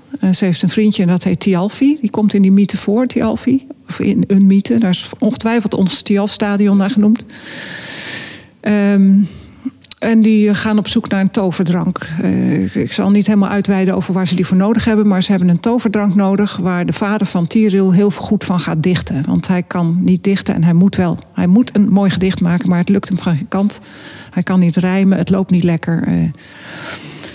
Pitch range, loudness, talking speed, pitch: 185-210 Hz, -14 LUFS, 210 wpm, 195 Hz